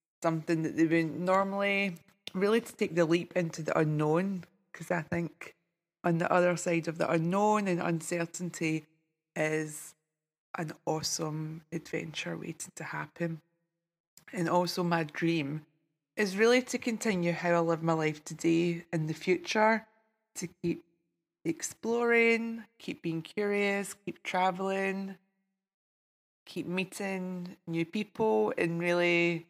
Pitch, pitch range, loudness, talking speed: 170 Hz, 165-195 Hz, -31 LUFS, 130 wpm